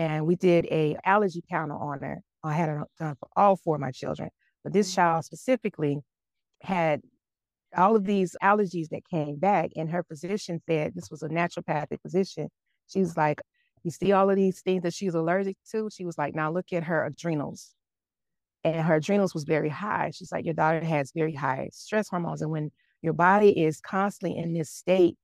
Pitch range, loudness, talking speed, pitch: 155-190 Hz, -27 LUFS, 200 wpm, 170 Hz